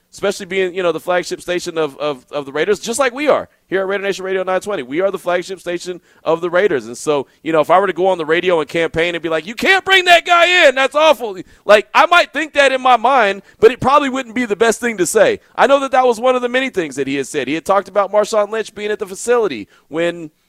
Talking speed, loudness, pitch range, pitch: 285 wpm, -15 LUFS, 175-255 Hz, 200 Hz